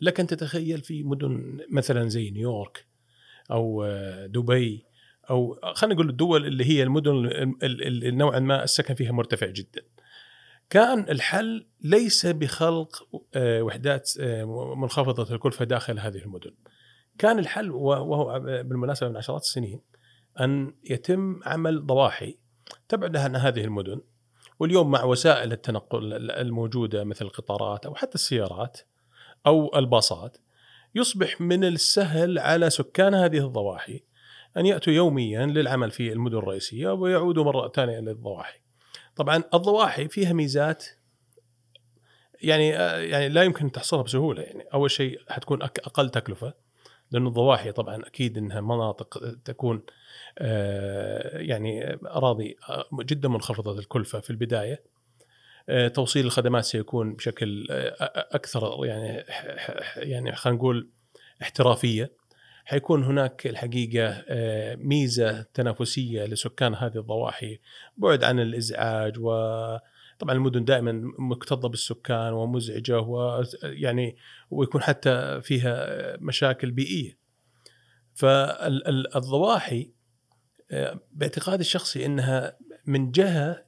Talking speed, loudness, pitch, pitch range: 105 wpm, -25 LUFS, 130 Hz, 115-145 Hz